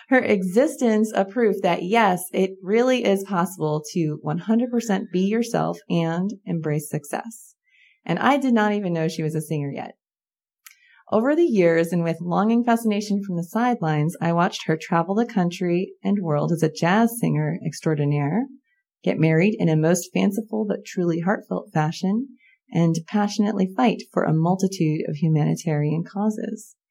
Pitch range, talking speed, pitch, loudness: 165-225 Hz, 155 wpm, 190 Hz, -22 LUFS